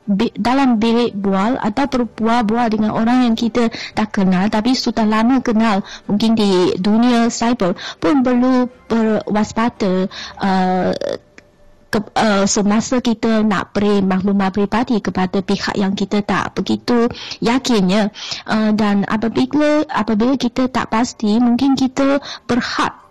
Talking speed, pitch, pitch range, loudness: 120 wpm, 225 Hz, 205-240 Hz, -16 LUFS